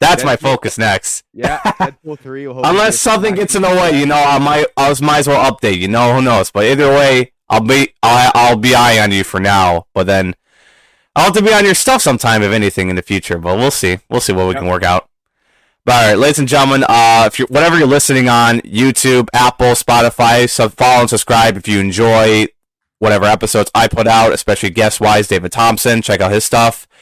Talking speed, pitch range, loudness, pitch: 220 wpm, 105-140 Hz, -11 LUFS, 120 Hz